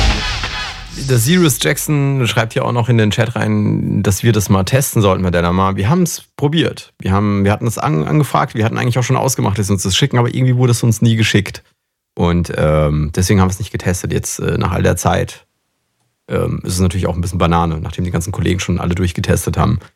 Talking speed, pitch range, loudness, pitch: 225 wpm, 90-125 Hz, -15 LUFS, 105 Hz